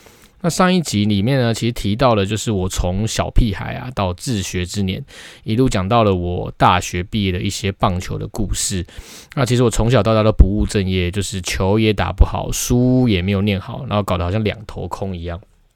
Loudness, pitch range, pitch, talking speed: -18 LUFS, 95-115 Hz, 105 Hz, 305 characters per minute